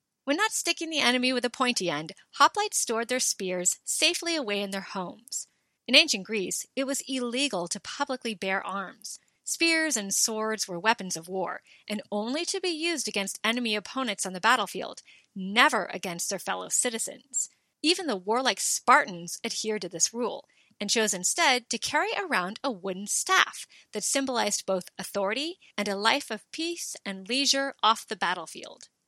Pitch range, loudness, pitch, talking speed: 195-275 Hz, -27 LUFS, 225 Hz, 170 wpm